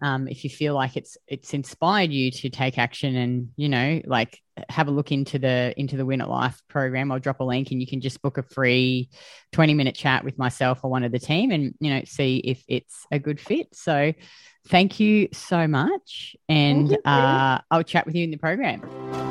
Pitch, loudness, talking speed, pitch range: 135 Hz, -23 LUFS, 220 wpm, 130-150 Hz